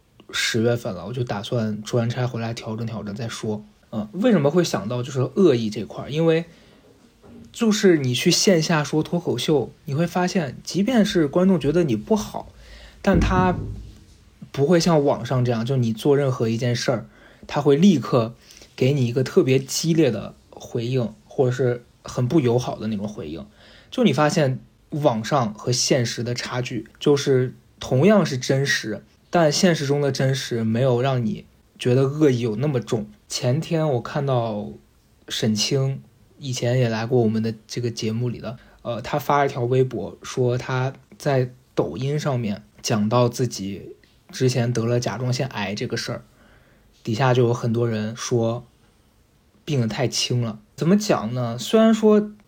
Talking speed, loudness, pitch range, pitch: 245 characters per minute, -22 LUFS, 115-150 Hz, 125 Hz